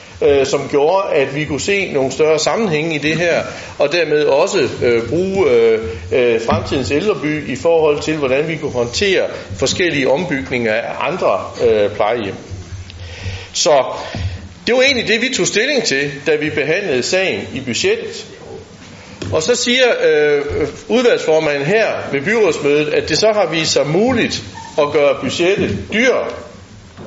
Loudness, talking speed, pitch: -15 LUFS, 150 wpm, 175 Hz